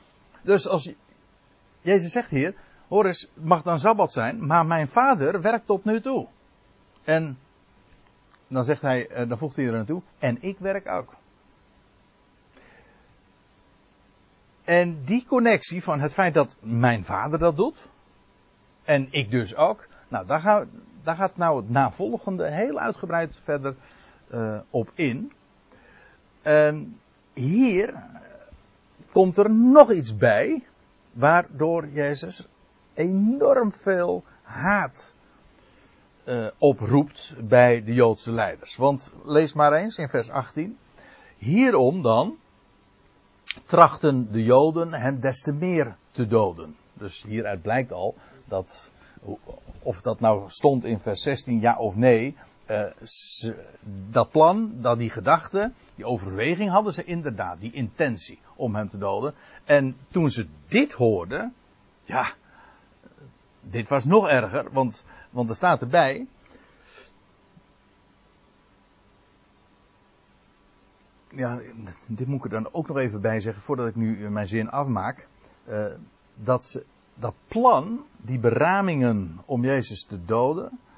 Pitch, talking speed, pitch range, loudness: 135 Hz, 125 wpm, 115-170 Hz, -23 LUFS